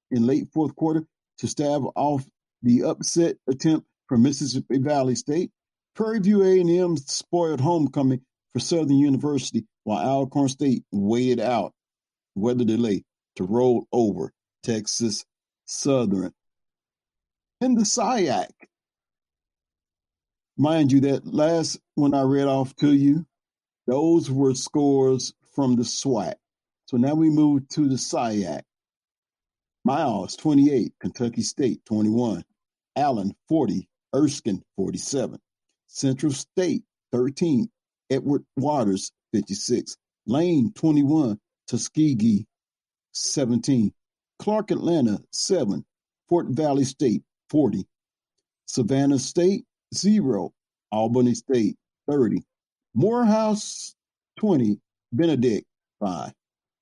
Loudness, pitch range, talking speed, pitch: -23 LUFS, 120-160 Hz, 105 wpm, 140 Hz